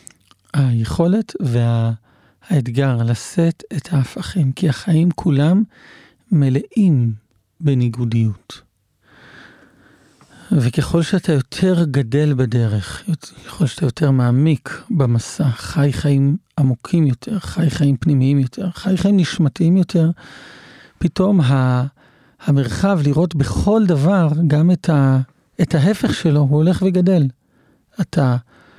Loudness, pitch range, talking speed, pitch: -17 LUFS, 130-175 Hz, 95 wpm, 145 Hz